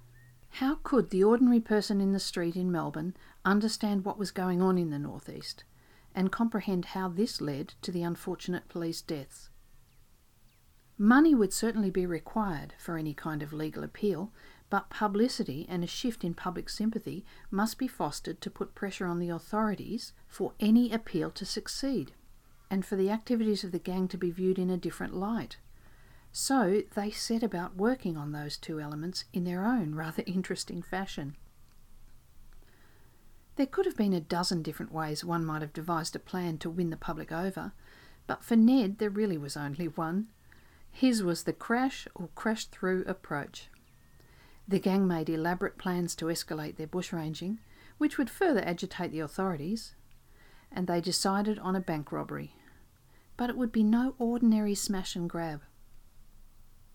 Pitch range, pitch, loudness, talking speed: 165-215 Hz, 185 Hz, -31 LUFS, 165 wpm